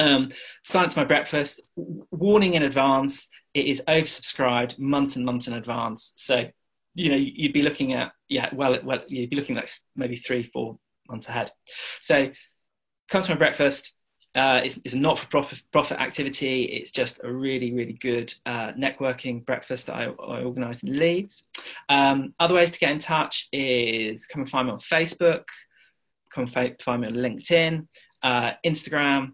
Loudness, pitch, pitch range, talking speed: -24 LUFS, 135 Hz, 125-155 Hz, 170 wpm